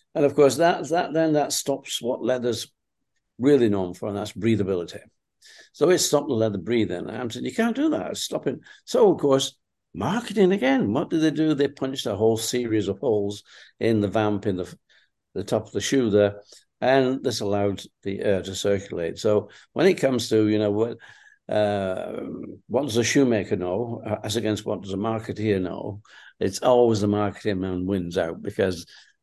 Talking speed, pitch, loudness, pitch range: 190 wpm, 115 Hz, -24 LUFS, 105-140 Hz